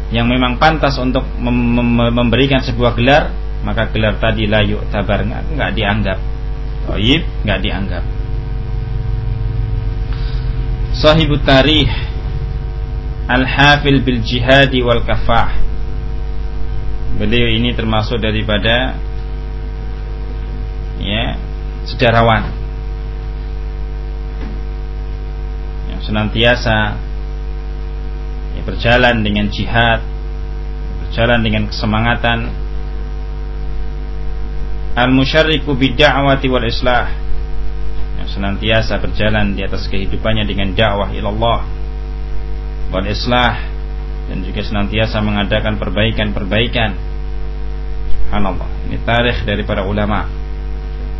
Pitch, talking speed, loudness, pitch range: 110 Hz, 75 wpm, -16 LUFS, 85-120 Hz